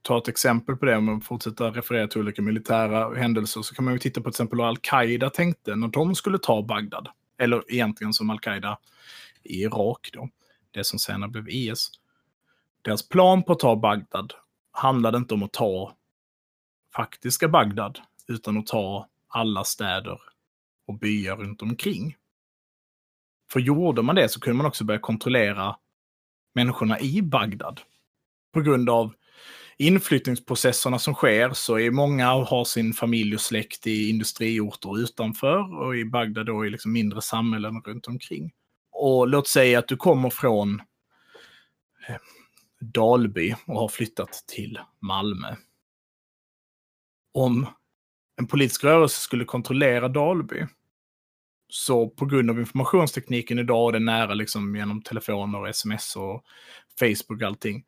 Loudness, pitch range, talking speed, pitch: -24 LUFS, 110-130 Hz, 145 wpm, 115 Hz